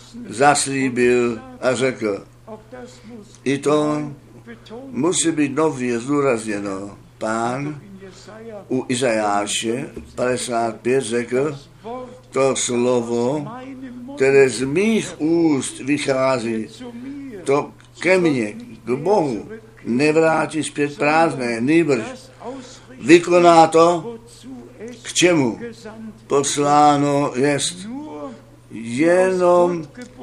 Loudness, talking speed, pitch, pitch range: -18 LUFS, 75 wpm, 140 Hz, 120-170 Hz